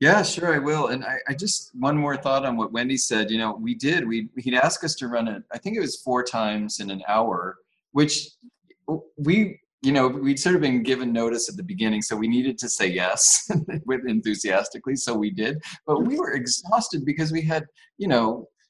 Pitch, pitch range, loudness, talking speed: 135 Hz, 115-160 Hz, -23 LUFS, 220 wpm